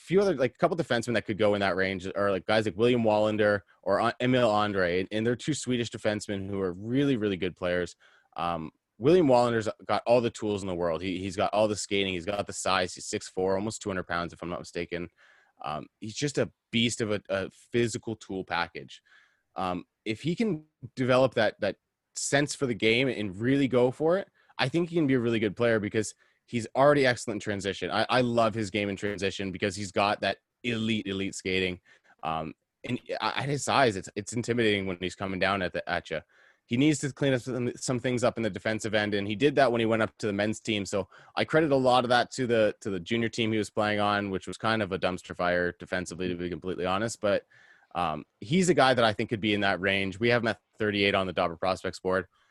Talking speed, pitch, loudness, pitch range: 240 wpm, 105 Hz, -28 LUFS, 95-120 Hz